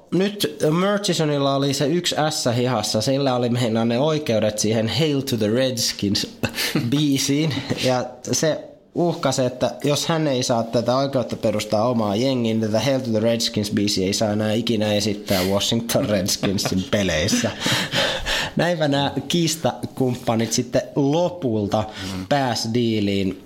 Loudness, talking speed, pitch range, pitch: -21 LUFS, 135 wpm, 110-140 Hz, 125 Hz